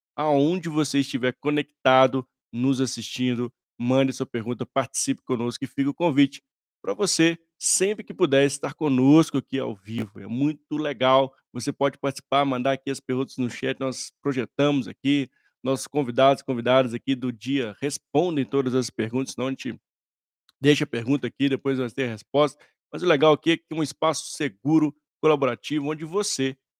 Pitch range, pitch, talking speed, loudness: 130-150 Hz, 135 Hz, 165 wpm, -24 LUFS